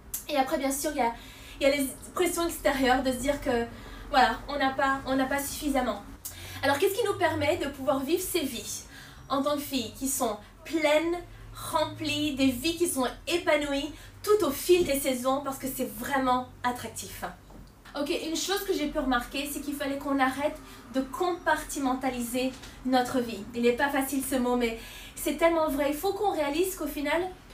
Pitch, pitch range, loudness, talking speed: 280 Hz, 265-315 Hz, -28 LUFS, 190 wpm